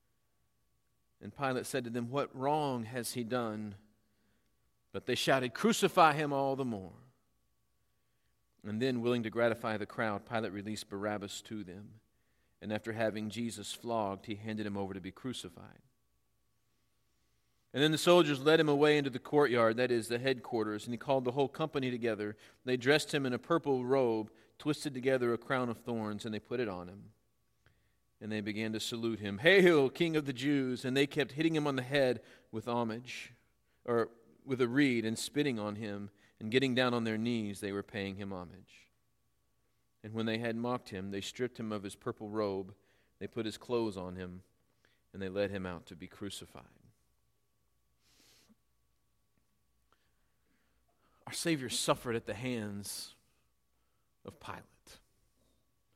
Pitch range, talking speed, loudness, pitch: 105-125 Hz, 170 wpm, -34 LUFS, 115 Hz